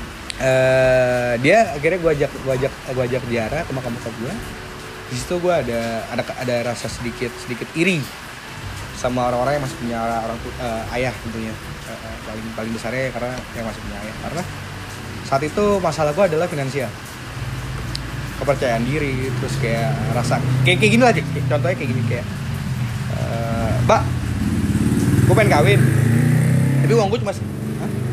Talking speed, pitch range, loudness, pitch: 160 wpm, 115-135 Hz, -20 LUFS, 125 Hz